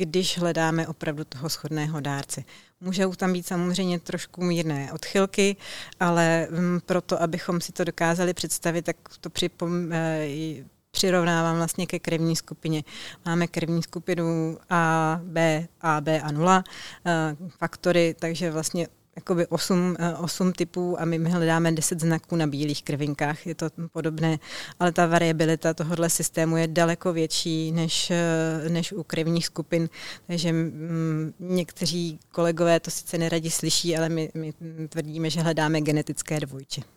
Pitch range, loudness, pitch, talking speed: 160-175 Hz, -26 LUFS, 165 Hz, 140 wpm